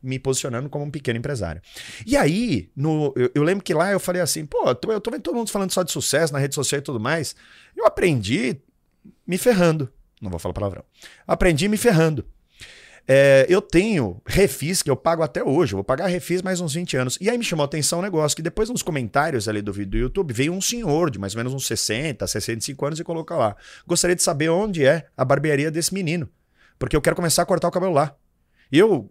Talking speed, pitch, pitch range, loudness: 235 wpm, 155 Hz, 130-180 Hz, -21 LUFS